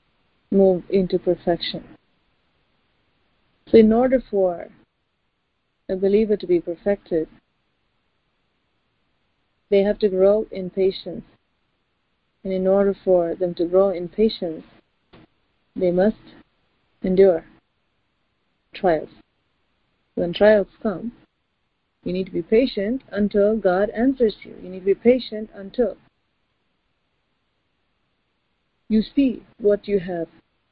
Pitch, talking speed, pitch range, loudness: 195 Hz, 105 wpm, 185-215 Hz, -21 LUFS